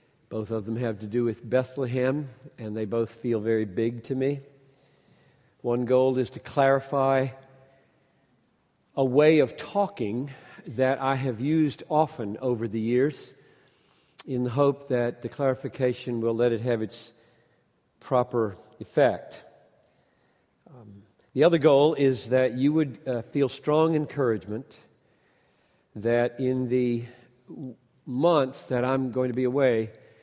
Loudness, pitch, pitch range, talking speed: -26 LUFS, 130 Hz, 120-135 Hz, 130 wpm